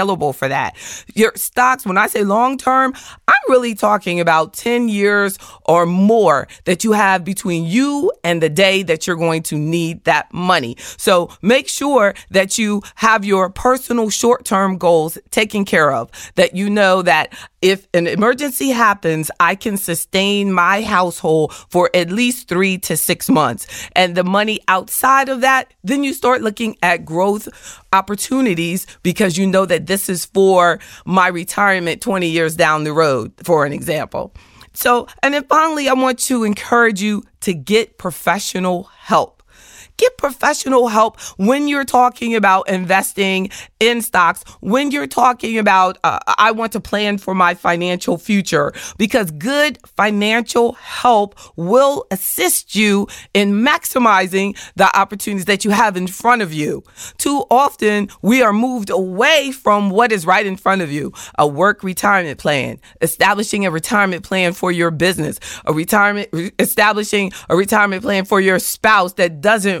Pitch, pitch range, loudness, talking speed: 200 Hz, 180-235 Hz, -15 LUFS, 160 wpm